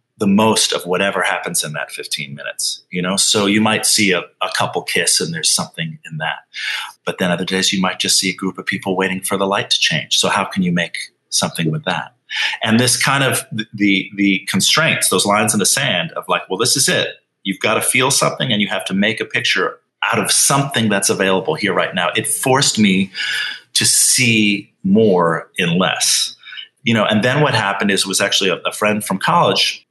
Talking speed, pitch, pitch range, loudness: 225 wpm, 100 Hz, 95-110 Hz, -15 LUFS